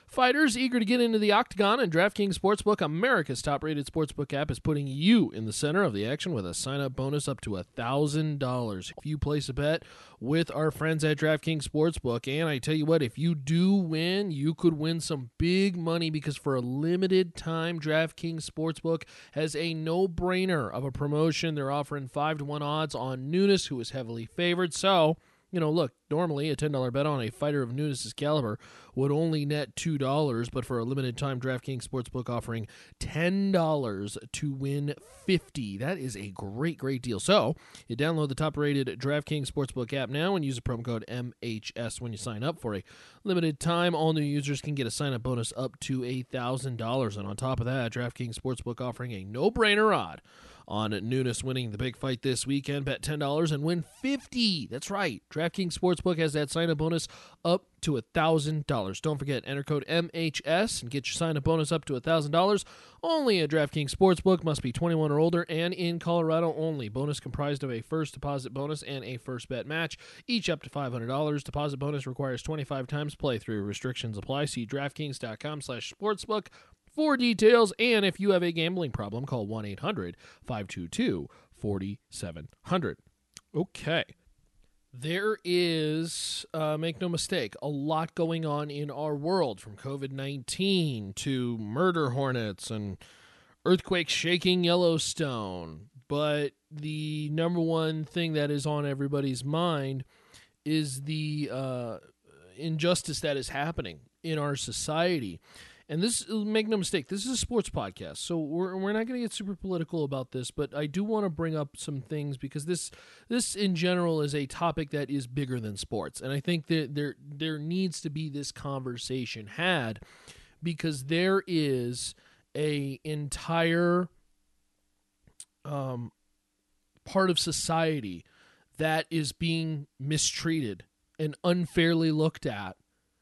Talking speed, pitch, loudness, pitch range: 170 wpm, 150 Hz, -30 LUFS, 130-165 Hz